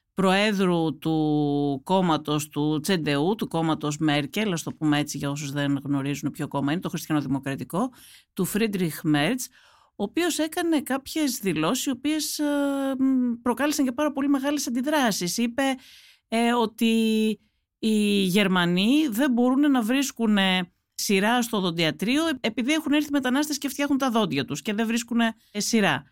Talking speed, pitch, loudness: 140 wpm, 220 Hz, -24 LUFS